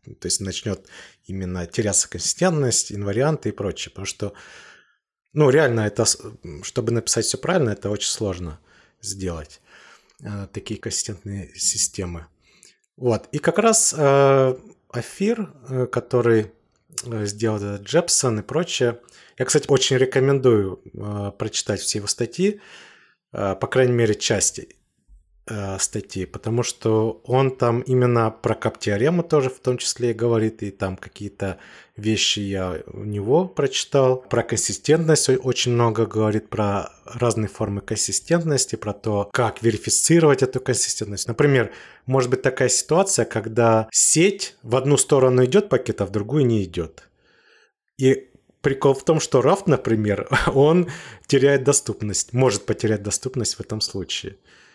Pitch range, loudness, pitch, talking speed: 105-130 Hz, -21 LUFS, 115 Hz, 135 wpm